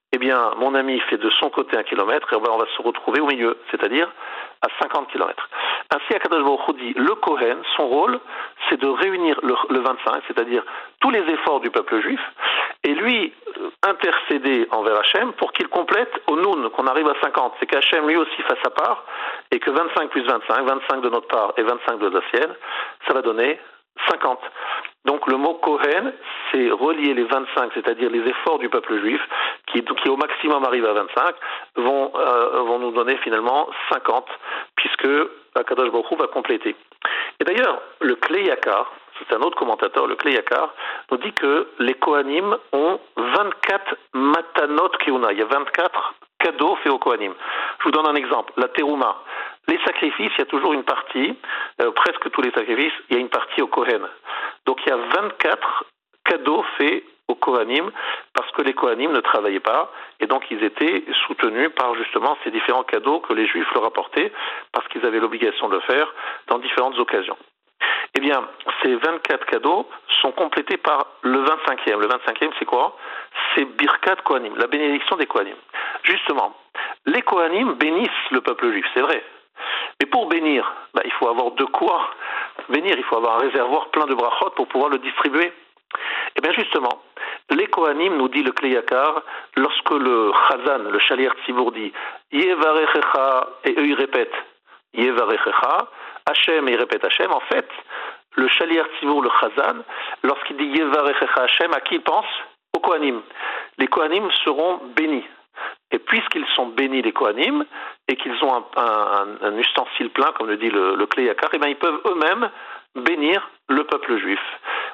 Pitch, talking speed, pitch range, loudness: 390 Hz, 180 wpm, 300-430 Hz, -20 LUFS